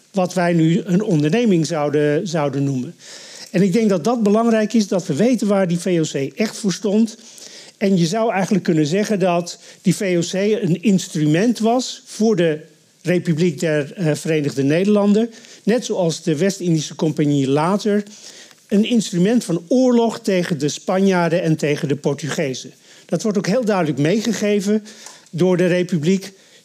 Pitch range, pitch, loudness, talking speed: 160-210 Hz, 185 Hz, -18 LUFS, 155 wpm